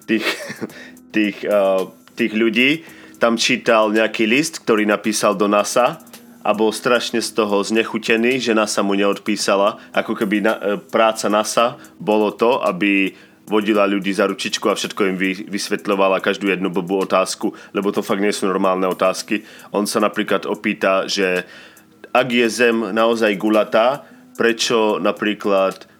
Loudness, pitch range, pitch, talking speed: -18 LUFS, 100-115 Hz, 105 Hz, 145 wpm